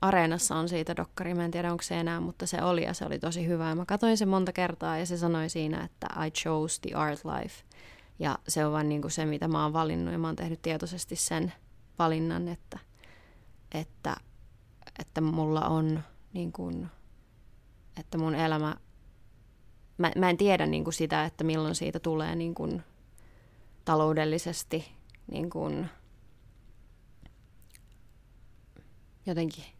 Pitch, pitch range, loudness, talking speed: 155 Hz, 110-165 Hz, -31 LUFS, 155 wpm